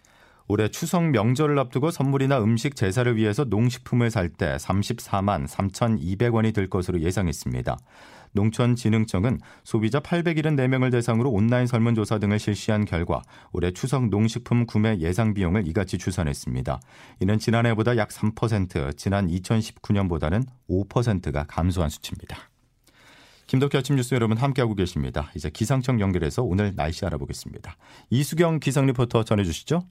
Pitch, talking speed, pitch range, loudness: 110 Hz, 335 characters per minute, 95-125 Hz, -24 LUFS